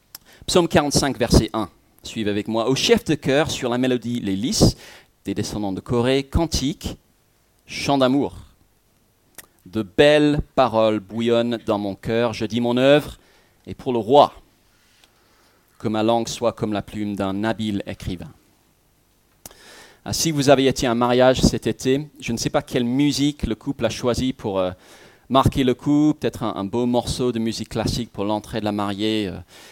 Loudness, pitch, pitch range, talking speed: -21 LUFS, 115 Hz, 105-130 Hz, 175 wpm